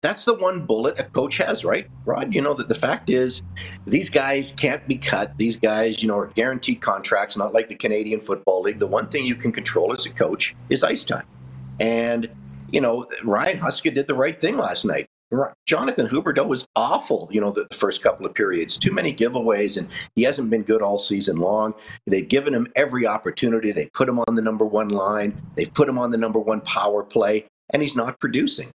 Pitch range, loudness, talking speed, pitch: 105-130 Hz, -22 LUFS, 215 wpm, 110 Hz